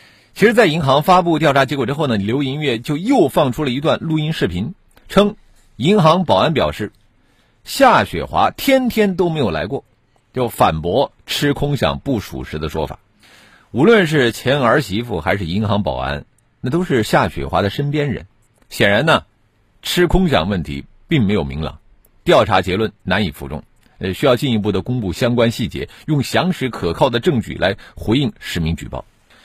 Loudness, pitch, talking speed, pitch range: -17 LUFS, 115 Hz, 265 characters per minute, 95-150 Hz